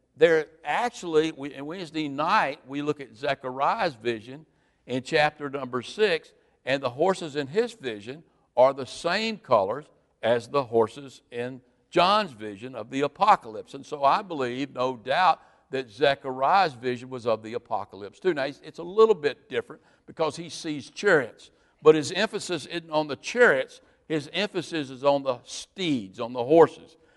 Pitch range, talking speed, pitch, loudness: 130-195 Hz, 165 wpm, 150 Hz, -26 LUFS